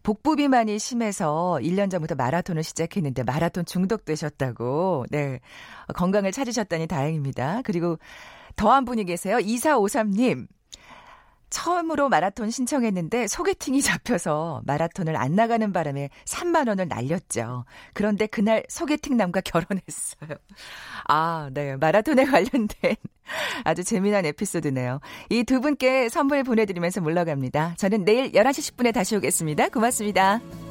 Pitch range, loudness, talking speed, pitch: 160-240 Hz, -24 LUFS, 315 characters per minute, 200 Hz